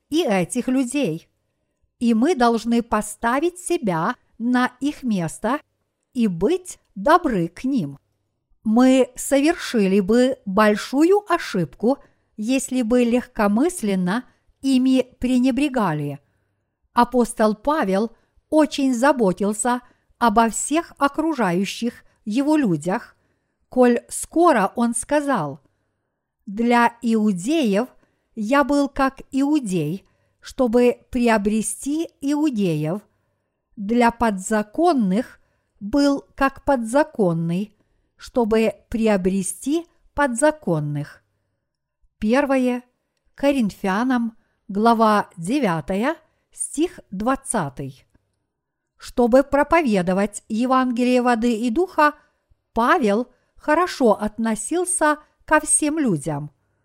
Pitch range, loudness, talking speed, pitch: 200-280 Hz, -20 LUFS, 80 wpm, 240 Hz